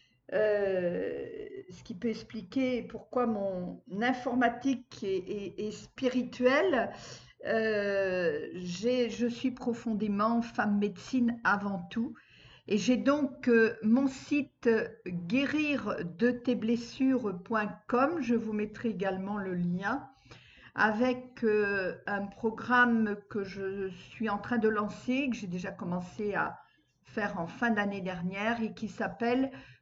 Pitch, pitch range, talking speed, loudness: 220 Hz, 200-245 Hz, 125 wpm, -31 LUFS